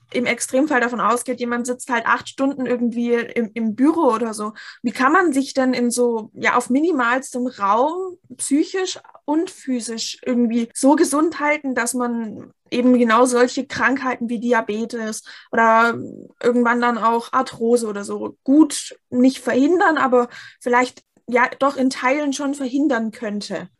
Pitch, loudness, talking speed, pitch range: 245 Hz, -19 LUFS, 150 wpm, 235-270 Hz